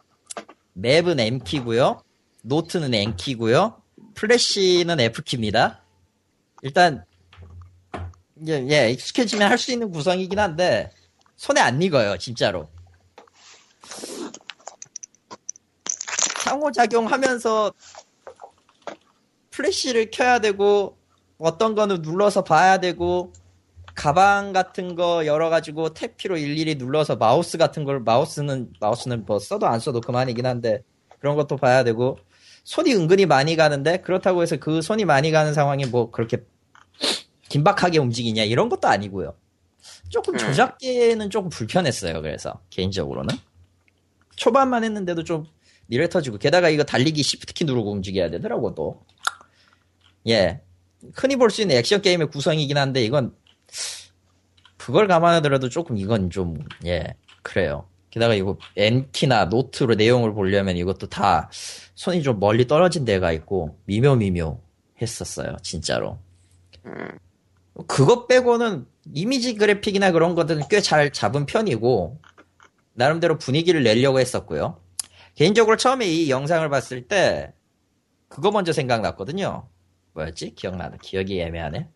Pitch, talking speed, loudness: 140 Hz, 290 characters per minute, -21 LUFS